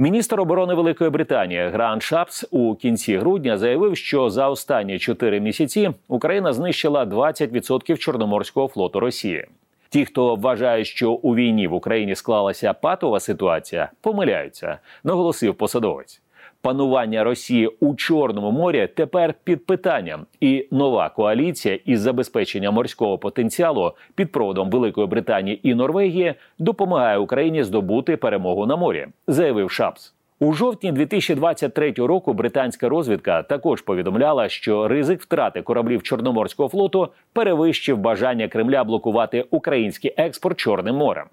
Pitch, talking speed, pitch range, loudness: 140 Hz, 125 wpm, 120-170 Hz, -20 LUFS